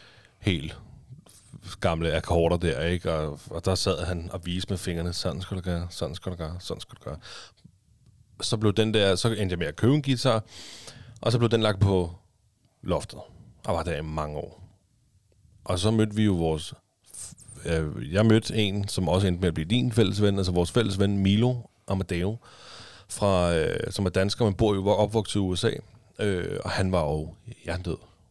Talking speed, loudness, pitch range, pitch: 195 wpm, -26 LUFS, 90-110 Hz, 95 Hz